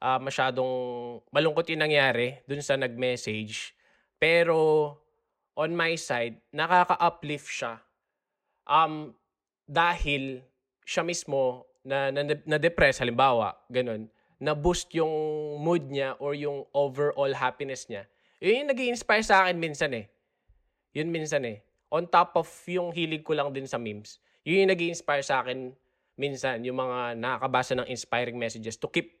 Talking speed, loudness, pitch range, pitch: 140 wpm, -27 LUFS, 125-165 Hz, 140 Hz